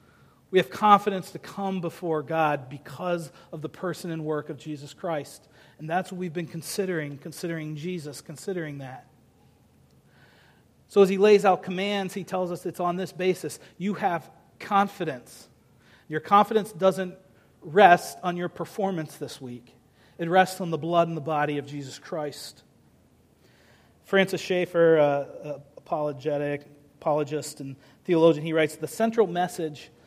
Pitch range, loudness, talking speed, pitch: 150-185 Hz, -26 LUFS, 150 wpm, 165 Hz